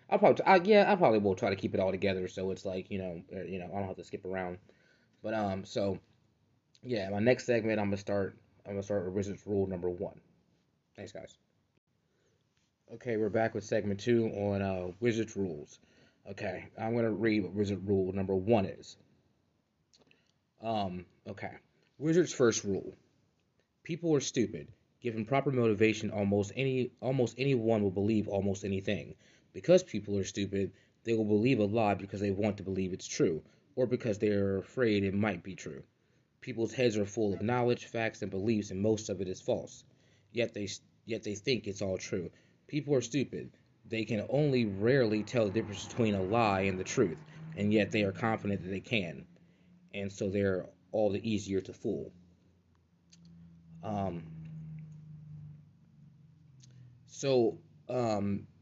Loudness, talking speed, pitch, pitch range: -32 LUFS, 175 wpm, 105 Hz, 100-120 Hz